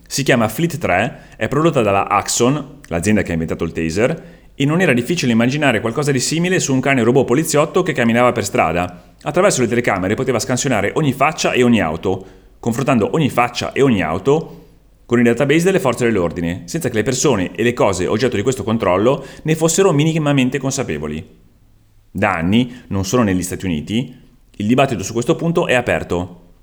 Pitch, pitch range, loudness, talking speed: 125 Hz, 100-145 Hz, -17 LUFS, 185 wpm